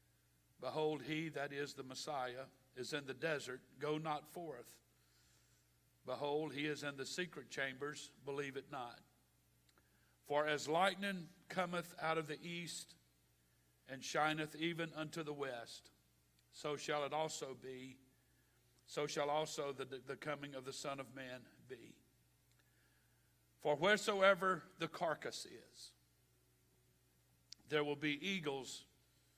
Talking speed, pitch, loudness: 130 wpm, 140 Hz, -42 LUFS